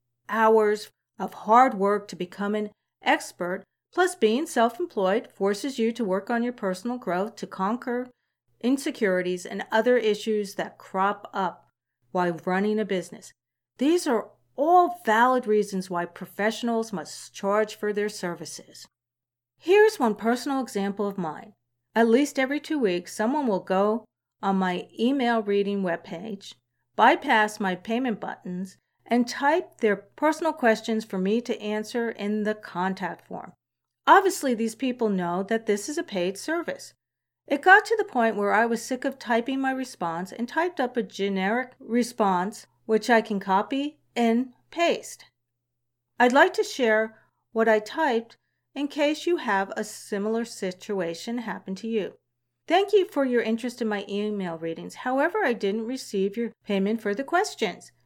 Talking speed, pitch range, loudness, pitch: 155 wpm, 195-245 Hz, -25 LUFS, 220 Hz